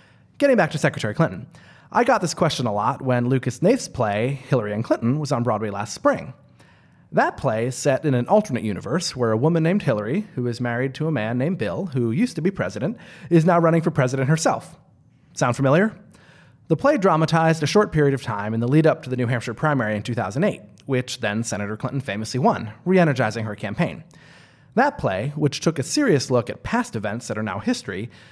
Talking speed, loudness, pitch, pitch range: 210 wpm, -22 LUFS, 135 Hz, 120-165 Hz